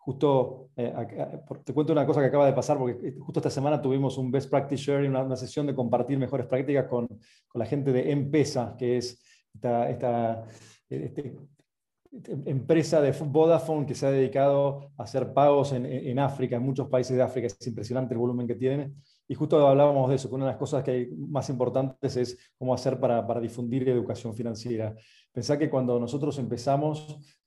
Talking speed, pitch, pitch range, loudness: 200 wpm, 130 Hz, 125-140 Hz, -27 LUFS